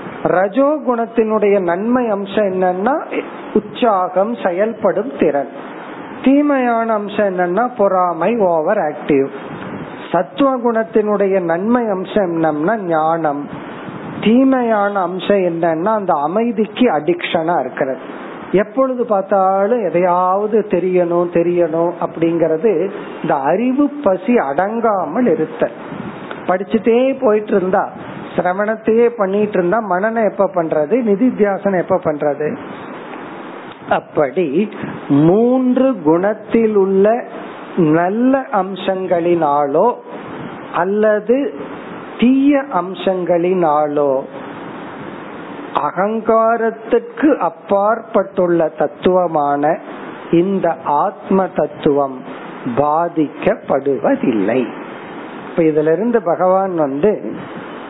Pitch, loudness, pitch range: 195 Hz, -16 LUFS, 170-225 Hz